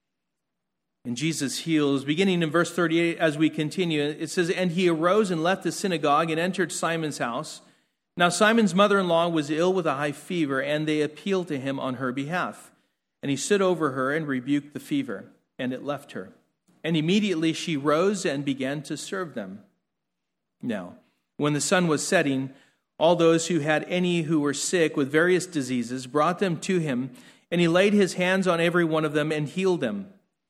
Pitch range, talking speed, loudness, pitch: 145-180 Hz, 195 wpm, -25 LUFS, 160 Hz